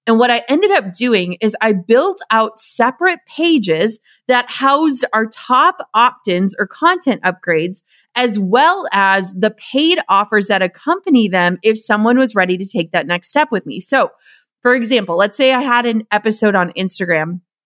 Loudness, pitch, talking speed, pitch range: -15 LUFS, 220 Hz, 175 wpm, 190-255 Hz